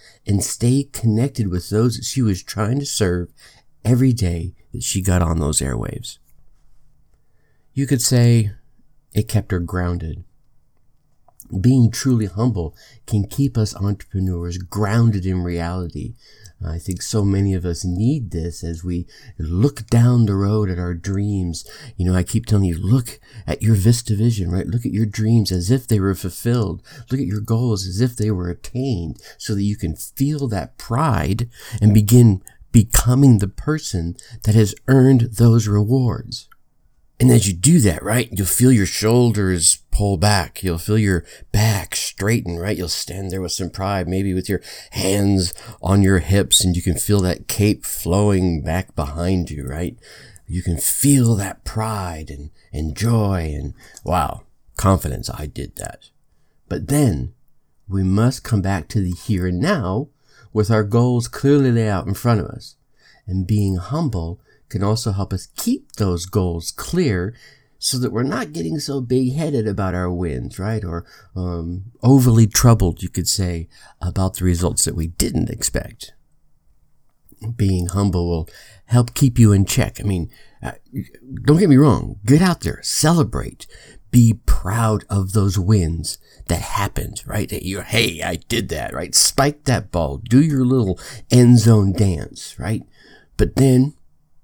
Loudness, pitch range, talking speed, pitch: -19 LUFS, 90-120 Hz, 165 wpm, 105 Hz